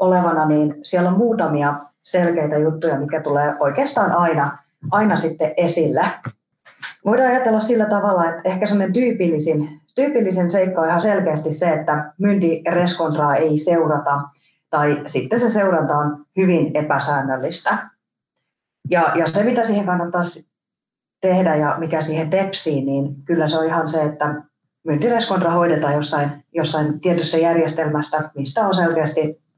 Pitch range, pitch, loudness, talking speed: 150-185 Hz, 160 Hz, -19 LUFS, 135 wpm